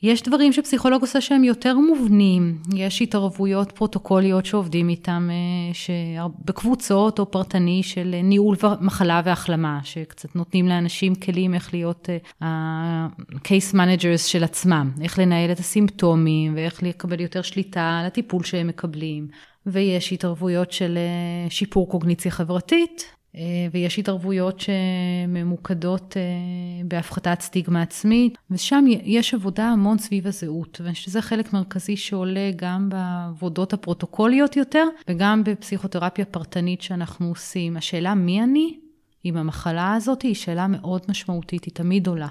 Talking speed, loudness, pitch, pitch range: 125 wpm, -22 LUFS, 185 Hz, 175-200 Hz